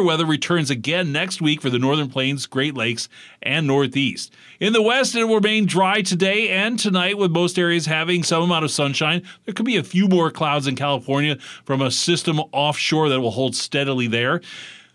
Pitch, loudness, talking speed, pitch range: 160 Hz, -19 LUFS, 195 wpm, 140-185 Hz